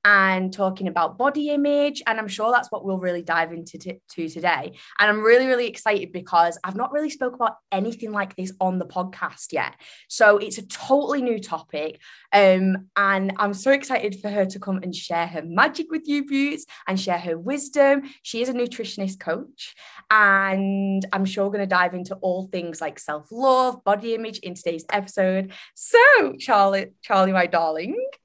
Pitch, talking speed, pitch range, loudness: 200 Hz, 185 wpm, 180-235 Hz, -22 LUFS